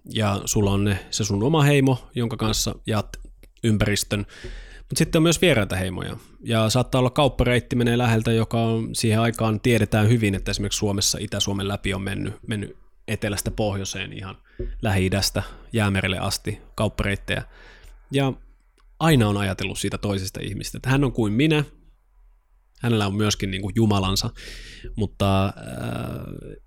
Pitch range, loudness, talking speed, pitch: 100-120 Hz, -23 LUFS, 145 wpm, 105 Hz